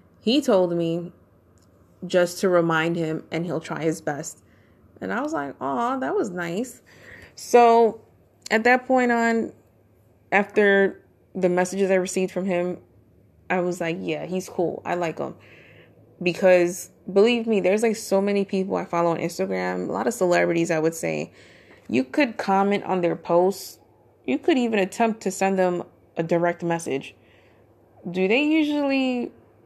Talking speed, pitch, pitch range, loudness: 160 wpm, 180 Hz, 160-200 Hz, -23 LUFS